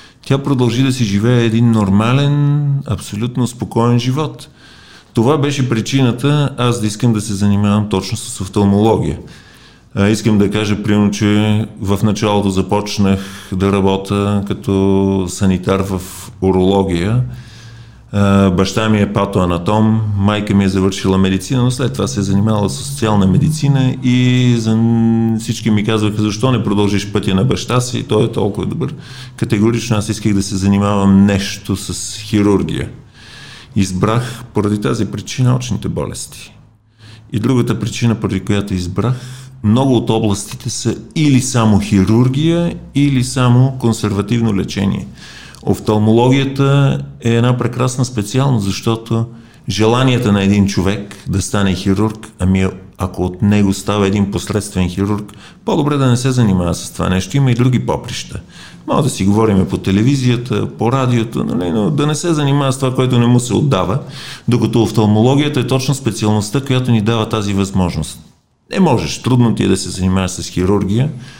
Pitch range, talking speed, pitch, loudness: 100-125 Hz, 150 wpm, 110 Hz, -15 LUFS